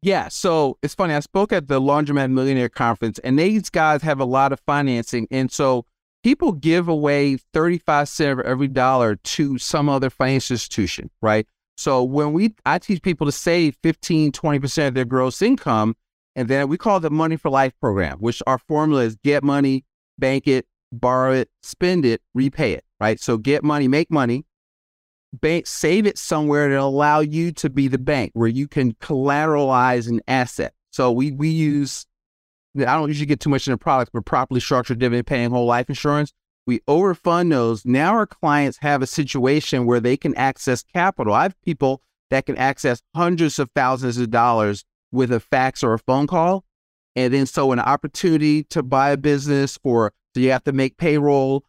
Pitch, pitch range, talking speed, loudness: 140 Hz, 125-155 Hz, 195 wpm, -20 LUFS